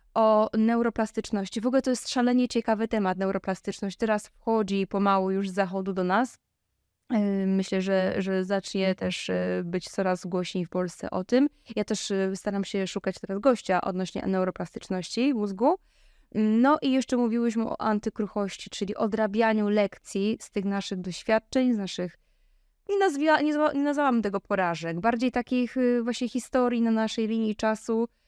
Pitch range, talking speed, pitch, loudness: 195-240 Hz, 145 wpm, 215 Hz, -27 LUFS